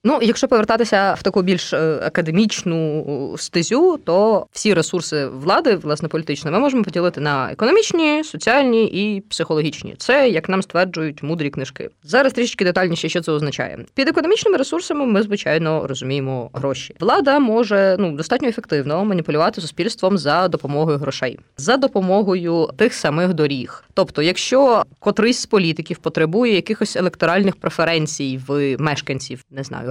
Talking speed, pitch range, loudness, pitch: 140 wpm, 150-220 Hz, -18 LUFS, 180 Hz